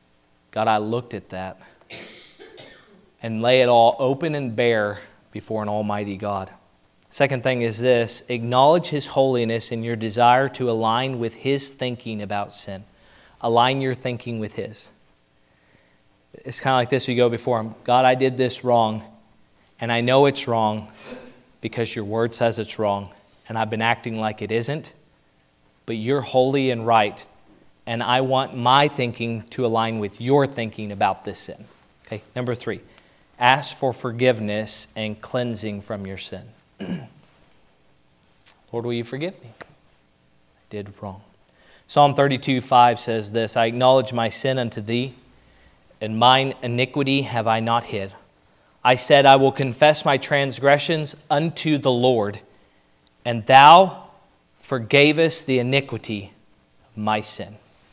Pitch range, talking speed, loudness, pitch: 105-130 Hz, 145 wpm, -20 LUFS, 115 Hz